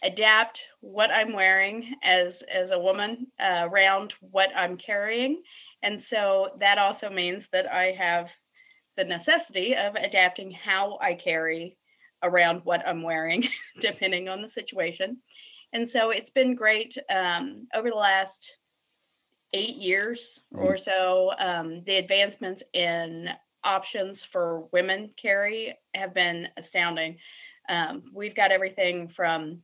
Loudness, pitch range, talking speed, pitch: -25 LUFS, 180-225 Hz, 130 wpm, 195 Hz